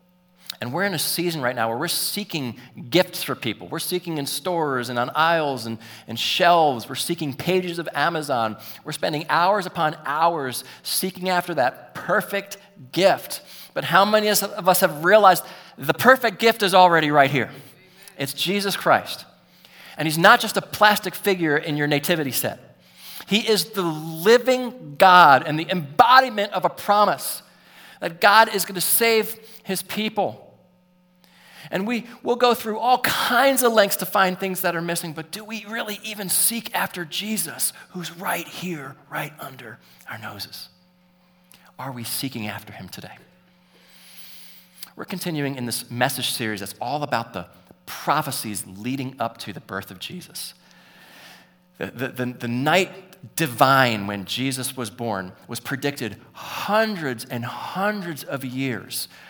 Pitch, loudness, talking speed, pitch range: 170 Hz, -21 LUFS, 160 wpm, 130-195 Hz